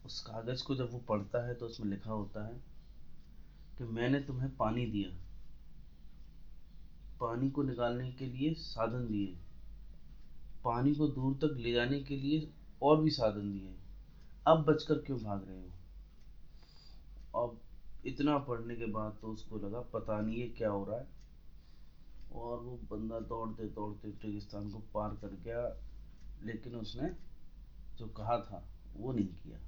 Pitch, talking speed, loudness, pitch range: 110 Hz, 150 wpm, -37 LUFS, 100-125 Hz